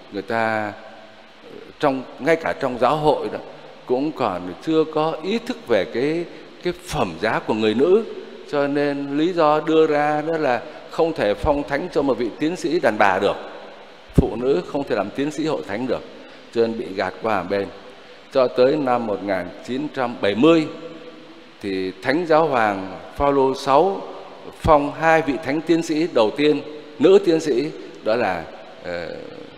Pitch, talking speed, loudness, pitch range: 150 Hz, 165 wpm, -21 LUFS, 115-160 Hz